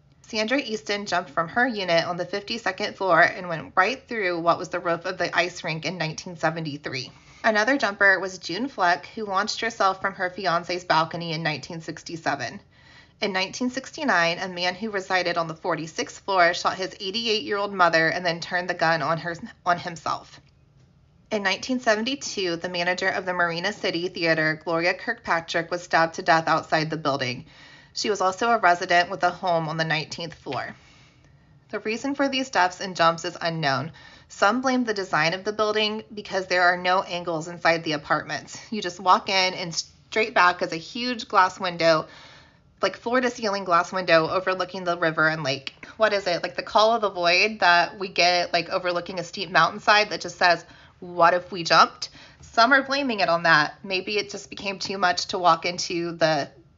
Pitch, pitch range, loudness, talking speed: 180 Hz, 170-200 Hz, -23 LUFS, 190 wpm